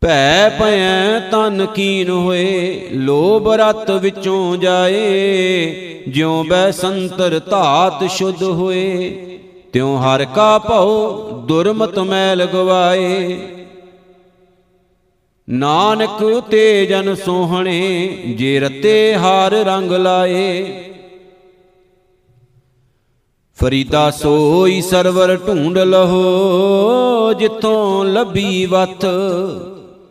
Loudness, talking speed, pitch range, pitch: -14 LUFS, 75 wpm, 180-195 Hz, 185 Hz